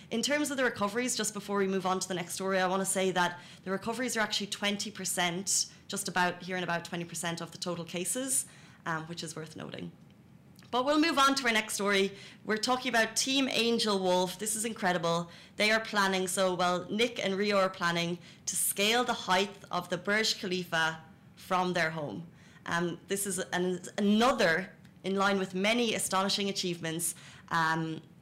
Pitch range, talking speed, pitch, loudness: 175-210 Hz, 190 wpm, 190 Hz, -30 LUFS